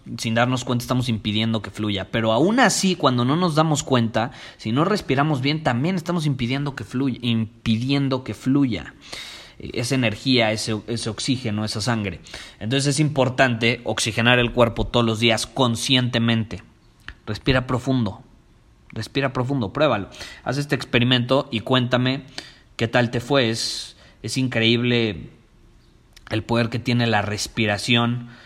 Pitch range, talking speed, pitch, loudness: 110-135 Hz, 140 wpm, 120 Hz, -21 LUFS